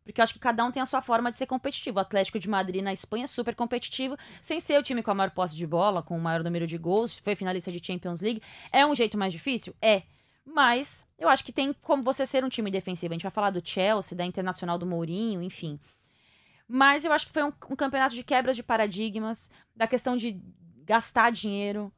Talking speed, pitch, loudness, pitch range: 240 wpm, 220 Hz, -28 LUFS, 185-255 Hz